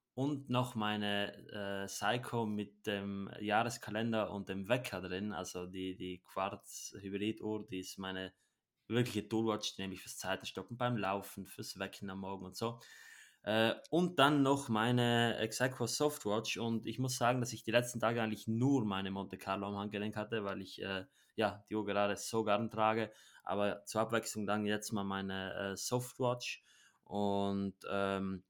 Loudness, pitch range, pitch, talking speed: -37 LUFS, 100-115 Hz, 105 Hz, 170 wpm